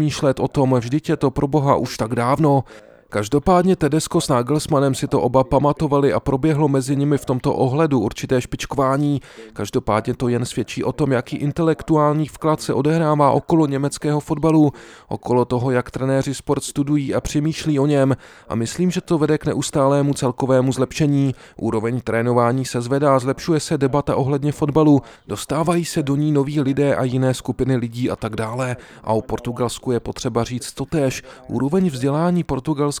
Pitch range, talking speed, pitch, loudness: 125-150 Hz, 165 wpm, 140 Hz, -19 LUFS